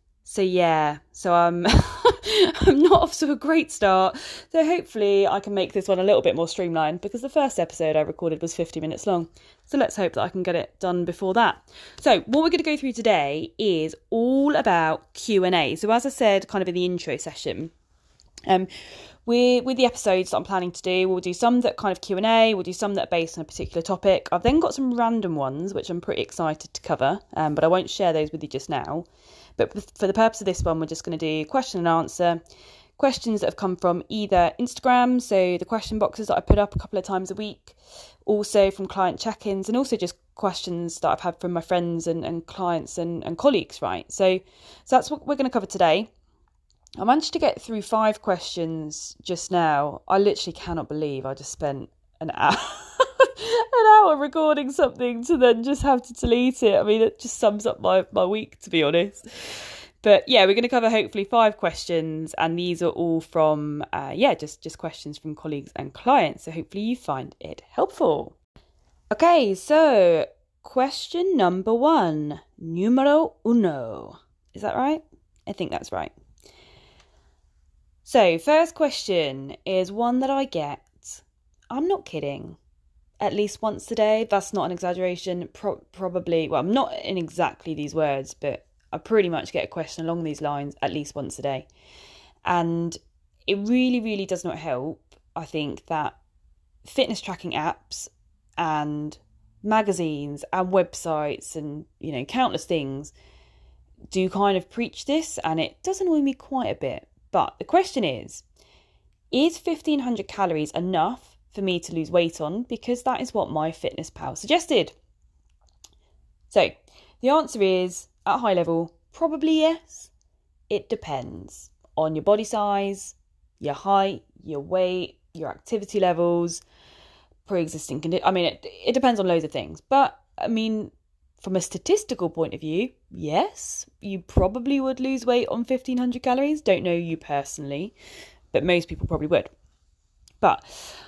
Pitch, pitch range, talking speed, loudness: 190 Hz, 160-245 Hz, 180 wpm, -23 LUFS